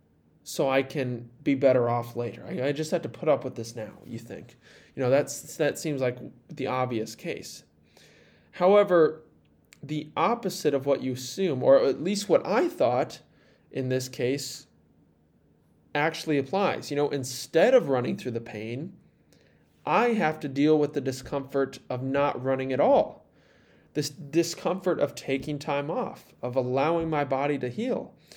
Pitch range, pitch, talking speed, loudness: 125-155 Hz, 140 Hz, 165 wpm, -27 LUFS